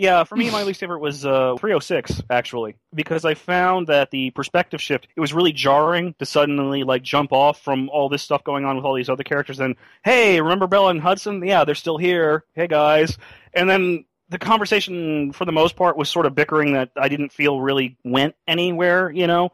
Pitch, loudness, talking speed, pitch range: 150 Hz, -19 LUFS, 210 wpm, 140-175 Hz